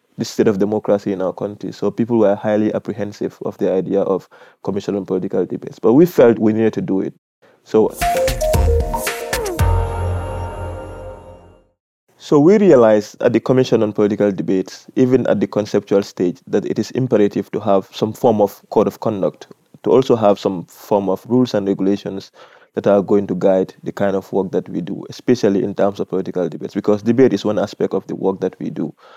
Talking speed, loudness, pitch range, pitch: 190 wpm, -17 LUFS, 95-105 Hz, 100 Hz